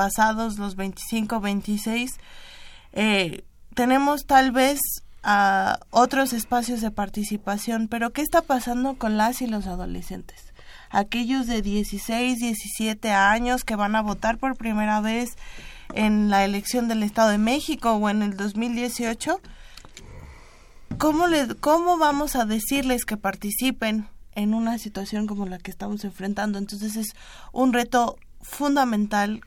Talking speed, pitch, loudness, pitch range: 135 wpm, 225 Hz, -24 LUFS, 210-250 Hz